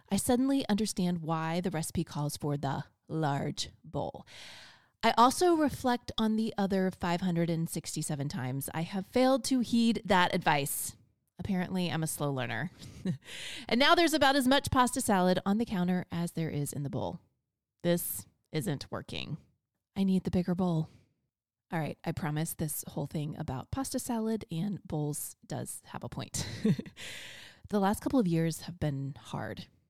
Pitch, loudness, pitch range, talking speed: 180 Hz, -31 LUFS, 155-215 Hz, 160 wpm